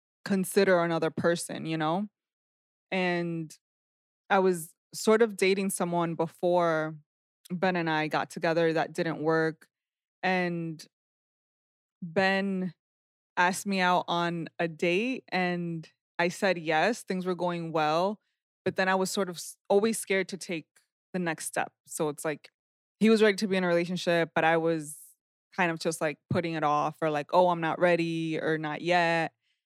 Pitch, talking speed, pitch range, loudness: 170 Hz, 160 wpm, 160-185 Hz, -28 LUFS